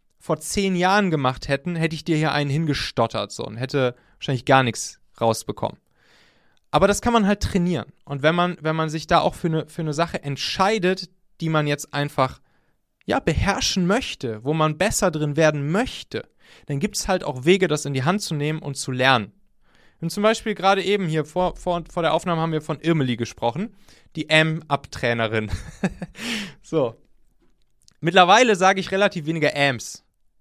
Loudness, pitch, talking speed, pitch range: -22 LUFS, 160 Hz, 180 wpm, 140-185 Hz